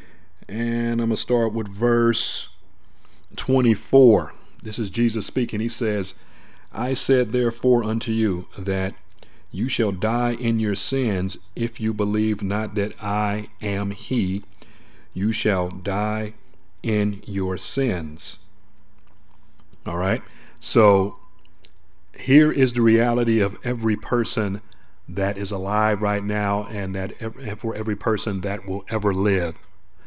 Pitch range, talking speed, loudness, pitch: 95-115 Hz, 130 wpm, -22 LUFS, 105 Hz